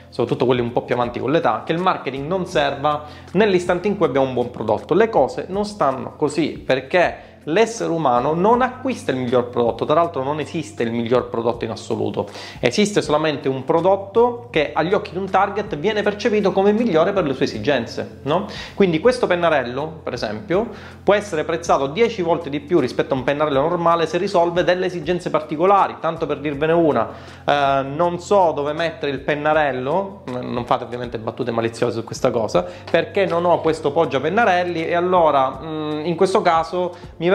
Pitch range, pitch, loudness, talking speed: 135-185 Hz, 165 Hz, -20 LUFS, 185 wpm